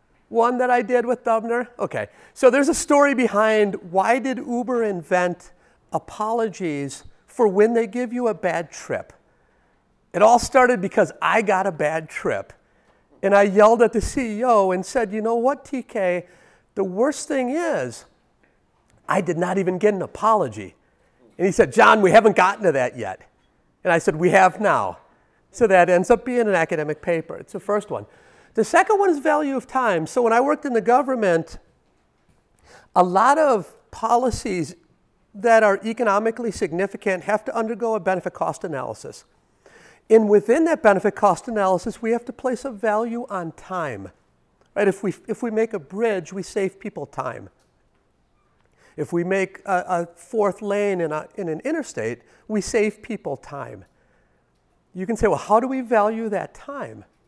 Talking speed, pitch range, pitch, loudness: 175 wpm, 185-240 Hz, 210 Hz, -20 LUFS